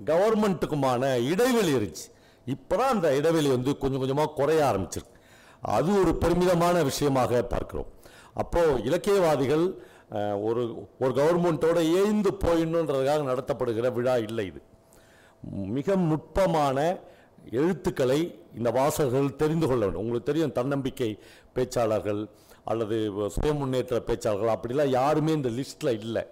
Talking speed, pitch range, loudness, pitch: 110 wpm, 120-165 Hz, -26 LUFS, 135 Hz